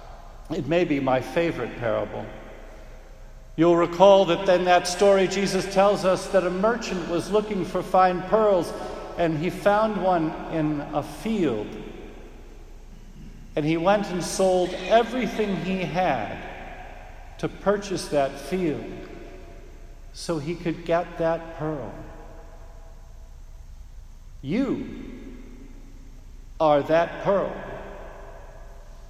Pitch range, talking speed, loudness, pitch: 145-190 Hz, 105 wpm, -23 LUFS, 170 Hz